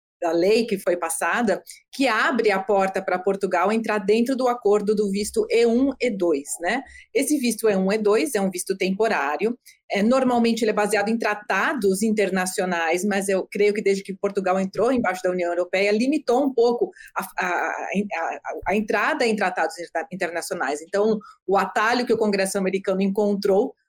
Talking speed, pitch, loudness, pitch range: 180 wpm, 205 Hz, -22 LUFS, 190-230 Hz